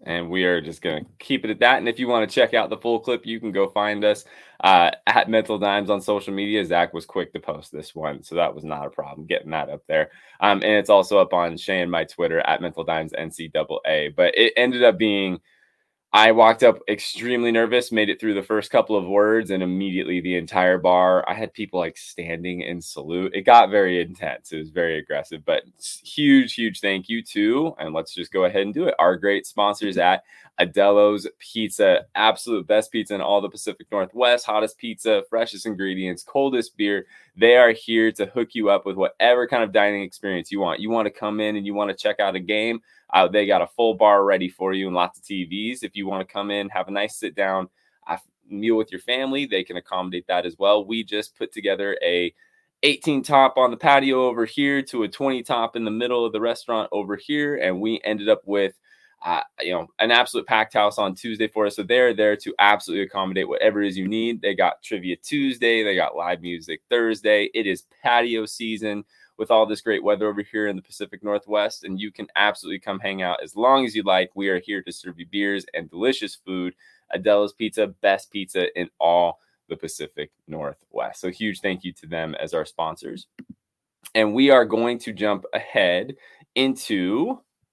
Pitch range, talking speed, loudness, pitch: 95-115 Hz, 220 wpm, -21 LUFS, 105 Hz